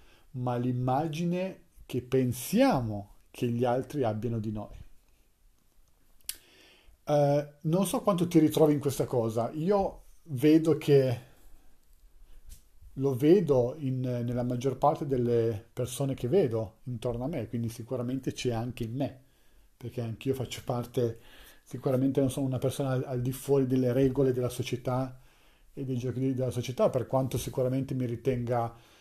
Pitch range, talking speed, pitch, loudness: 115-135 Hz, 140 wpm, 125 Hz, -29 LUFS